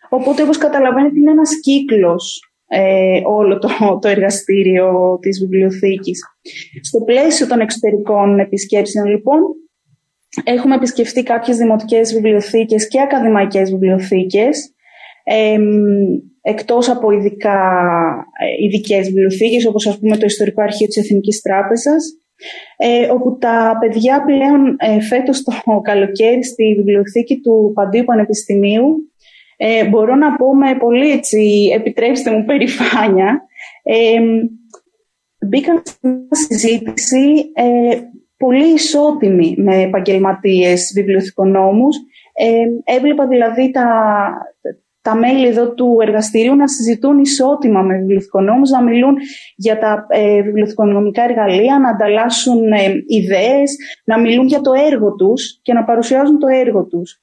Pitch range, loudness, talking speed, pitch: 205-265 Hz, -13 LUFS, 120 wpm, 230 Hz